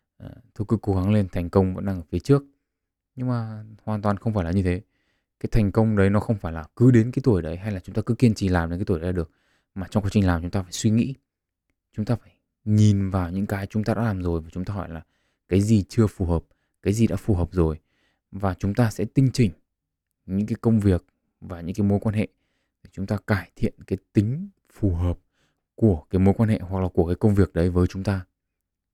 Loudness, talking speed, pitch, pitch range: -24 LUFS, 260 wpm, 100 Hz, 90-110 Hz